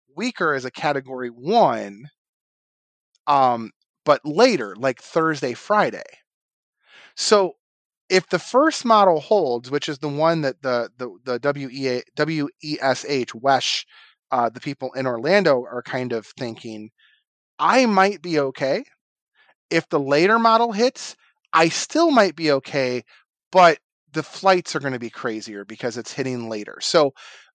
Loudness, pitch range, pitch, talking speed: -21 LUFS, 125-180 Hz, 145 Hz, 140 wpm